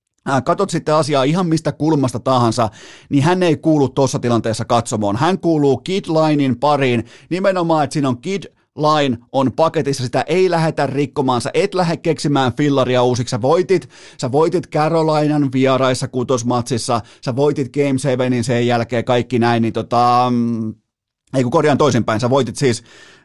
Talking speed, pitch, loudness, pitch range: 155 wpm, 135 Hz, -17 LUFS, 120-155 Hz